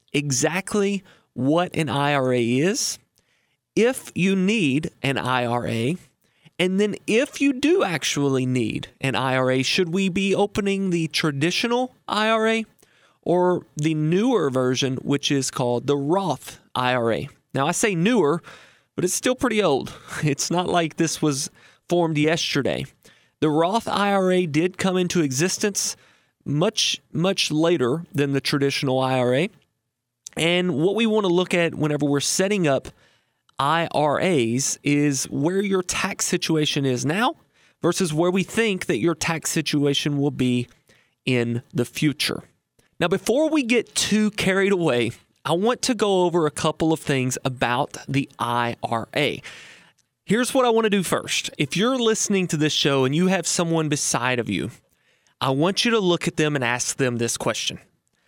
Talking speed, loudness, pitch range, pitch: 155 wpm, -22 LUFS, 135-190 Hz, 160 Hz